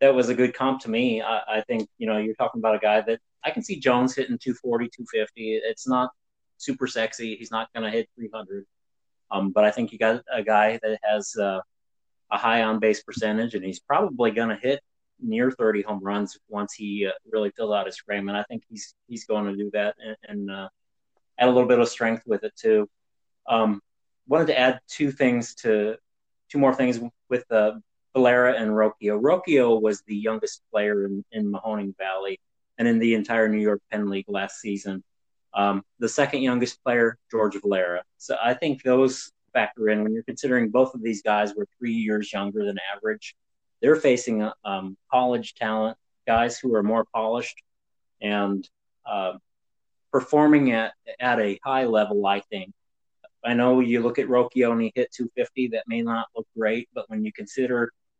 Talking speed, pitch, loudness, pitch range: 195 wpm, 110 Hz, -24 LUFS, 105-125 Hz